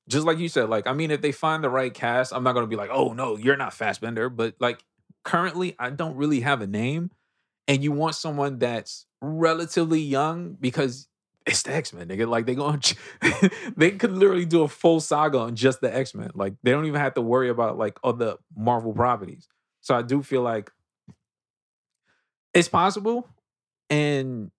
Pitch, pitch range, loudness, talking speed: 140 Hz, 120-160 Hz, -24 LUFS, 200 wpm